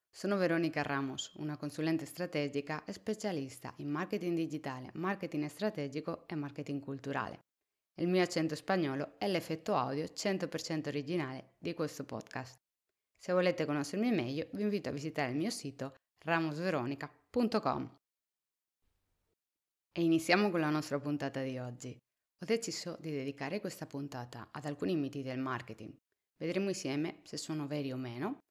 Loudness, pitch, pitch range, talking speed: -36 LUFS, 150 Hz, 140-170 Hz, 140 wpm